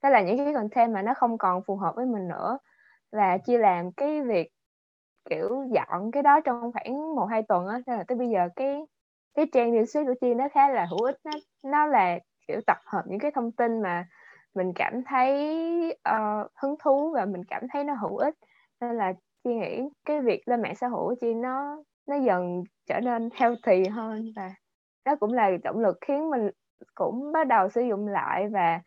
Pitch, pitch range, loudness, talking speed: 240 Hz, 205-280 Hz, -27 LUFS, 210 wpm